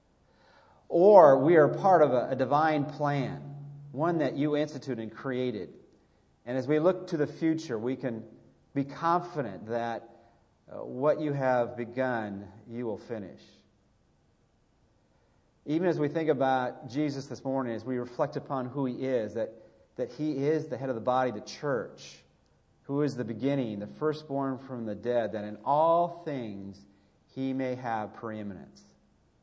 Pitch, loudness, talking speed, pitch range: 130 Hz, -29 LUFS, 155 wpm, 115-145 Hz